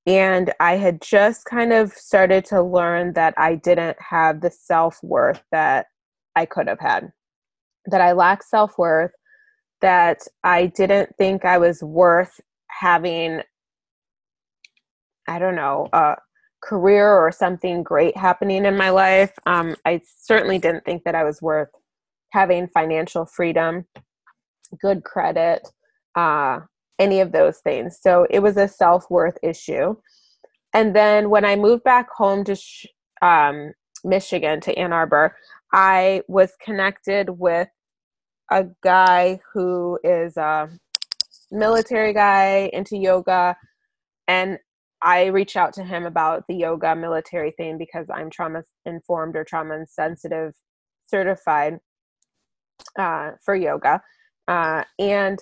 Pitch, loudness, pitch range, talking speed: 180 Hz, -19 LUFS, 165-195 Hz, 135 wpm